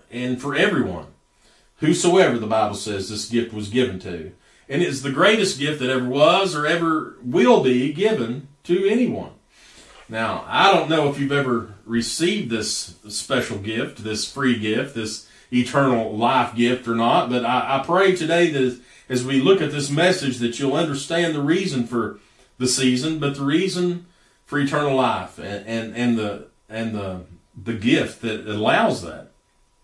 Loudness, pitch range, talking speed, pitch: -21 LUFS, 110-150 Hz, 170 wpm, 125 Hz